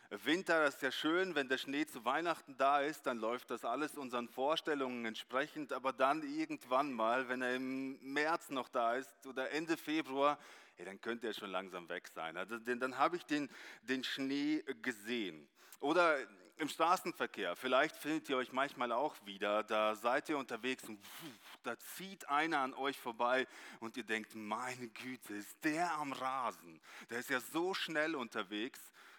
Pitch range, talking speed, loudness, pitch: 120-150 Hz, 175 wpm, -38 LUFS, 130 Hz